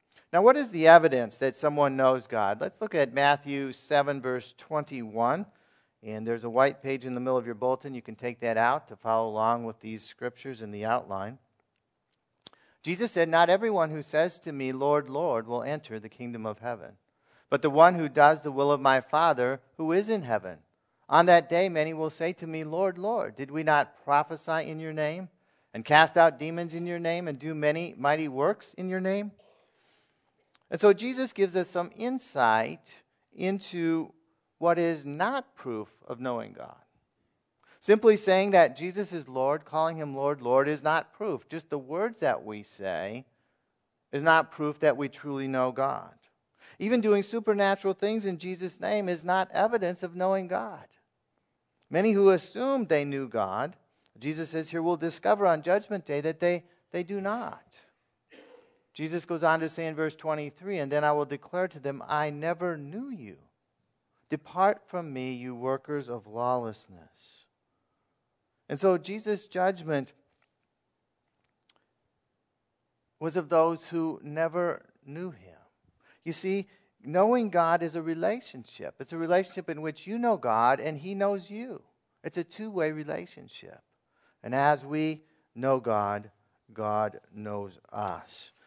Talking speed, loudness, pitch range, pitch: 165 wpm, -28 LUFS, 135-180 Hz, 155 Hz